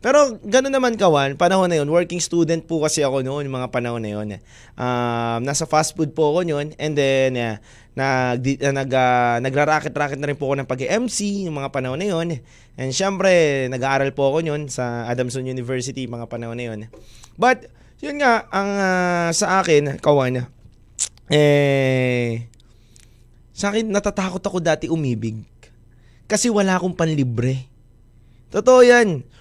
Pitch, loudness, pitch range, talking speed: 140 Hz, -20 LUFS, 120-175 Hz, 155 wpm